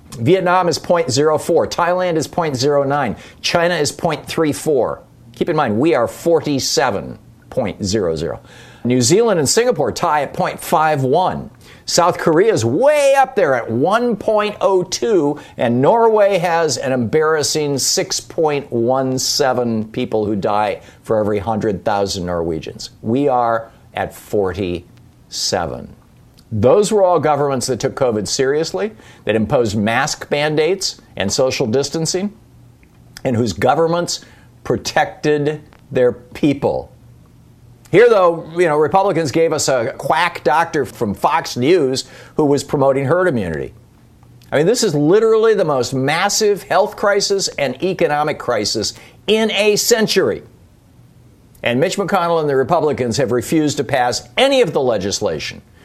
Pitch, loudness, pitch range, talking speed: 150 Hz, -16 LUFS, 125-185 Hz, 125 wpm